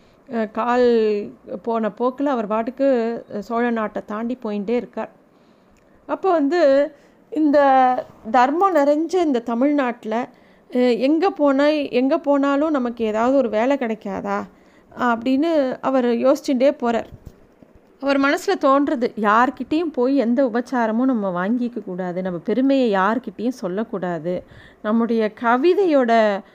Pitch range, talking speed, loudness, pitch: 220-280 Hz, 105 wpm, -20 LUFS, 245 Hz